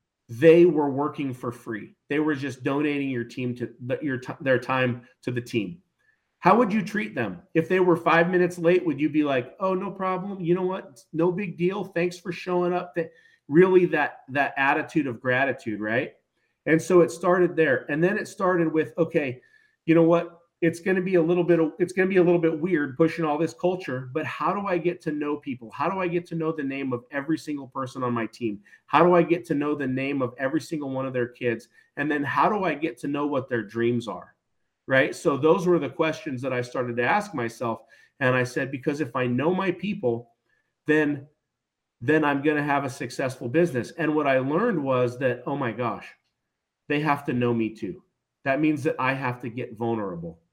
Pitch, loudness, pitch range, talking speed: 150 Hz, -25 LUFS, 130-170 Hz, 225 wpm